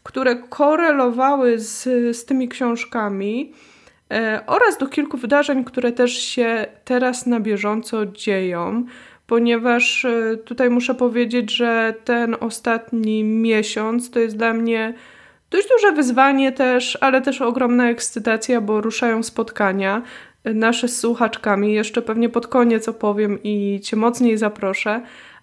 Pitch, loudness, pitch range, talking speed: 235 Hz, -19 LUFS, 220-250 Hz, 125 wpm